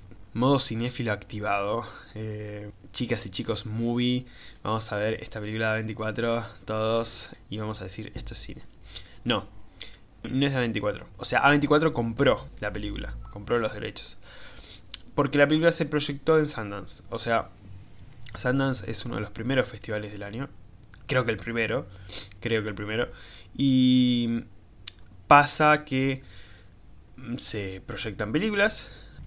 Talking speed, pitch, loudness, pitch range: 140 wpm, 110 Hz, -27 LUFS, 105-125 Hz